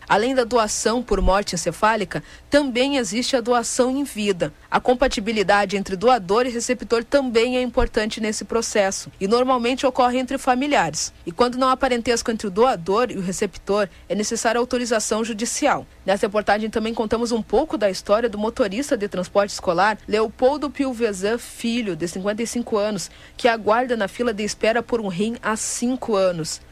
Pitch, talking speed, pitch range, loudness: 230 Hz, 165 wpm, 205-250 Hz, -21 LUFS